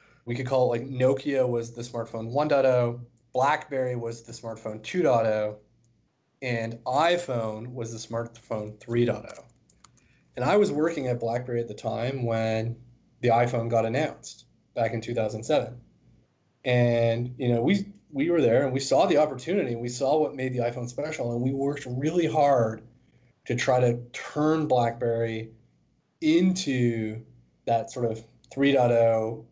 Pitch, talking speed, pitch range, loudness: 120 Hz, 150 wpm, 115-130 Hz, -26 LUFS